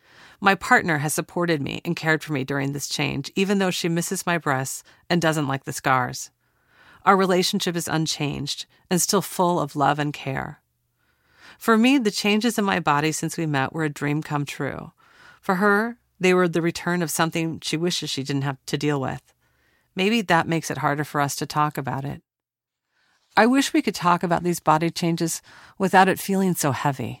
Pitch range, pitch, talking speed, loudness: 145-185 Hz, 165 Hz, 200 wpm, -22 LUFS